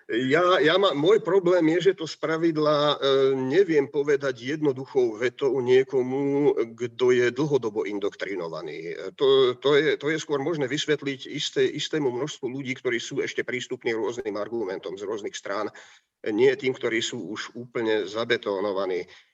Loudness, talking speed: -25 LUFS, 150 wpm